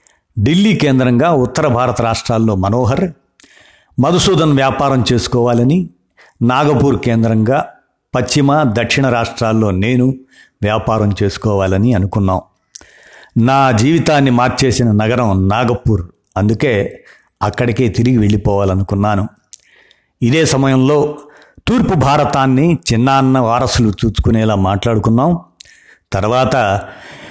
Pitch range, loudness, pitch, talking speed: 110-135 Hz, -13 LUFS, 120 Hz, 80 wpm